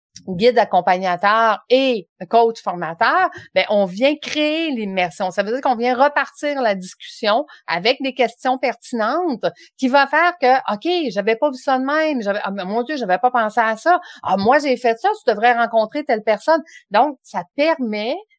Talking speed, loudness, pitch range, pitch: 180 wpm, -18 LUFS, 210-285 Hz, 240 Hz